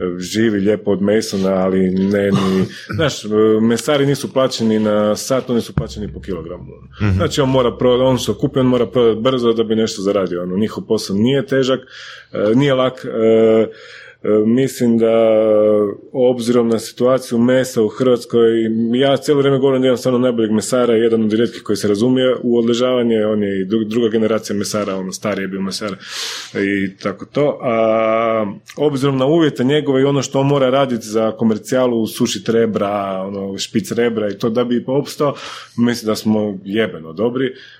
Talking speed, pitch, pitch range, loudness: 170 wpm, 115 Hz, 105-125 Hz, -16 LUFS